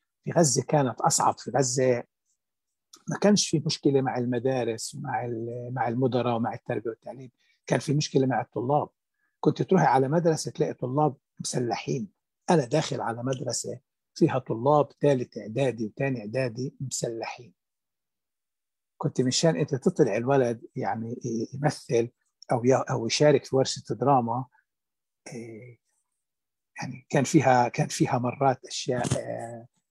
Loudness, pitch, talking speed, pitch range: -26 LUFS, 130 Hz, 120 wpm, 120-150 Hz